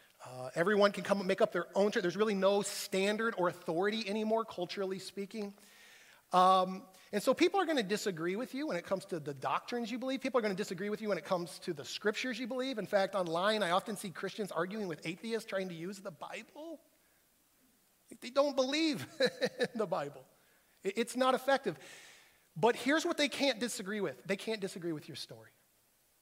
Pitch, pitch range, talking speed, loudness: 205 Hz, 185-245 Hz, 205 wpm, -34 LUFS